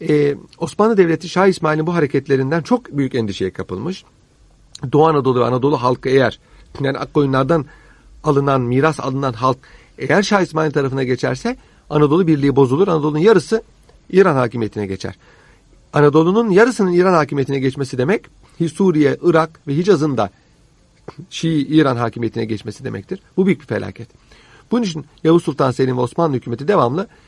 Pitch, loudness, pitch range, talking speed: 145 Hz, -17 LUFS, 130-165 Hz, 145 wpm